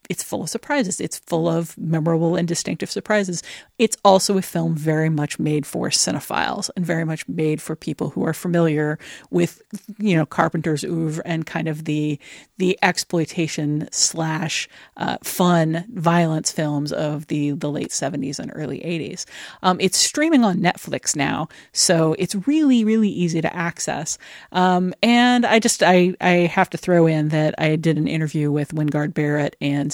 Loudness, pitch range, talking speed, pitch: -20 LUFS, 155-185 Hz, 170 wpm, 165 Hz